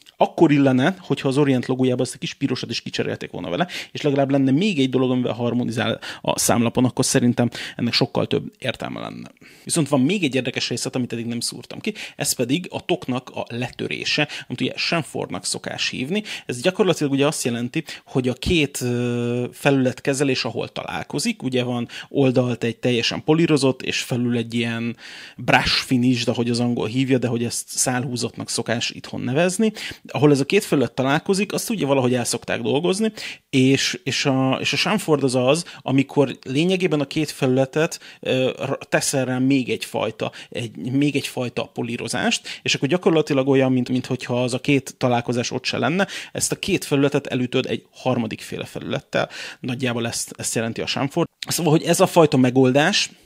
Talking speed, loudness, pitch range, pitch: 175 wpm, -21 LUFS, 125-145 Hz, 130 Hz